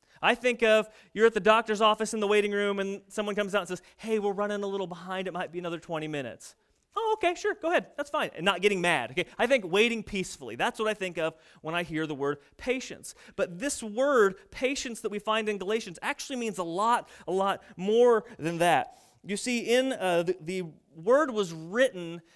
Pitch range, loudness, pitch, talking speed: 180-235 Hz, -28 LUFS, 205 Hz, 225 wpm